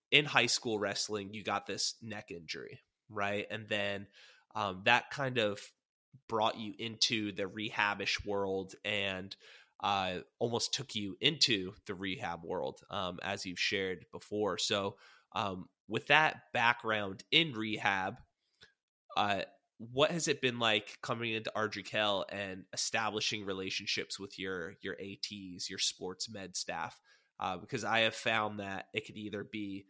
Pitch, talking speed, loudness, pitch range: 105 Hz, 145 wpm, -34 LUFS, 95-110 Hz